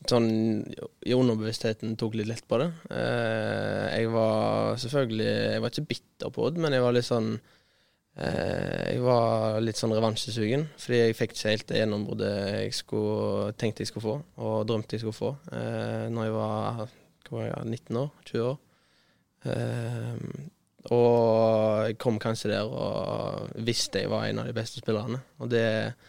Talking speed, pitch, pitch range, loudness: 155 wpm, 115 Hz, 110-120 Hz, -28 LUFS